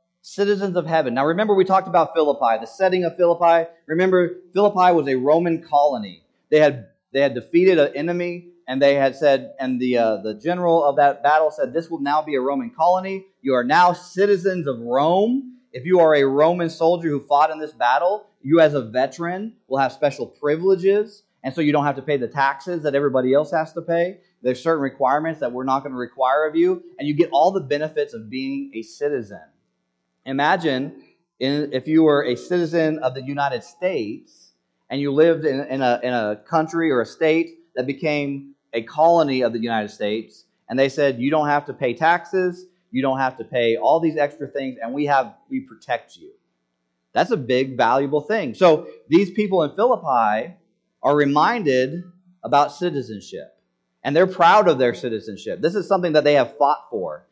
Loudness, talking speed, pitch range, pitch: -20 LUFS, 200 wpm, 135-180 Hz, 155 Hz